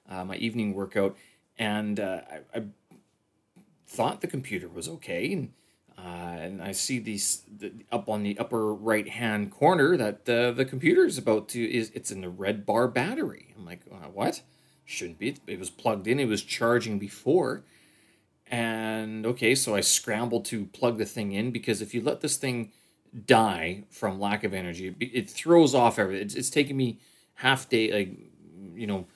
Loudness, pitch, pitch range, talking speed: -27 LUFS, 110 Hz, 100-120 Hz, 185 wpm